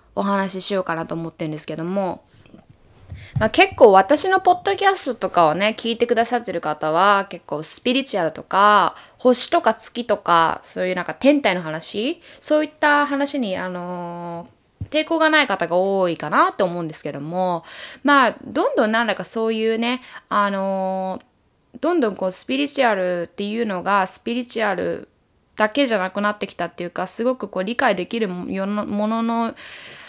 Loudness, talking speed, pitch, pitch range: -20 LUFS, 355 characters per minute, 205 Hz, 180-245 Hz